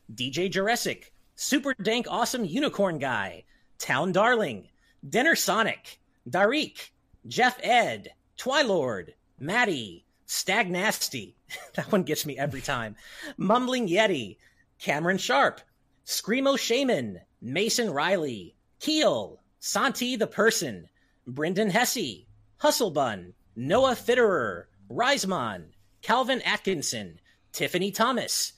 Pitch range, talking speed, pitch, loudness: 155-245 Hz, 95 wpm, 210 Hz, -26 LUFS